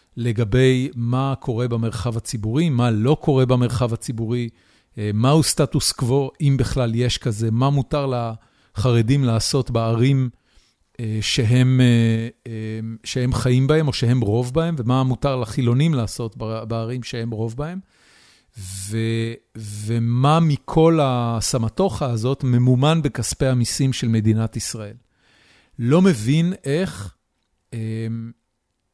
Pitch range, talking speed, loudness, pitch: 115-135 Hz, 110 wpm, -20 LUFS, 120 Hz